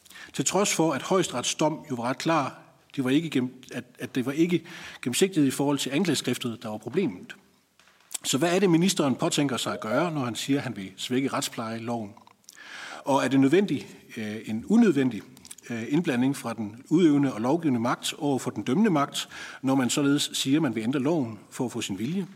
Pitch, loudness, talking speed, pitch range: 135 Hz, -26 LUFS, 190 wpm, 125-160 Hz